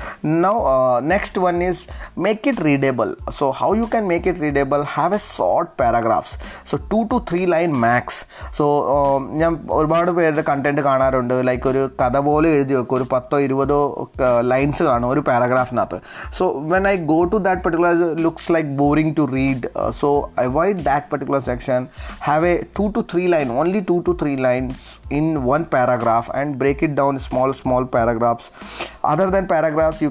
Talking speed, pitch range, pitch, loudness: 170 wpm, 130-170 Hz, 145 Hz, -19 LUFS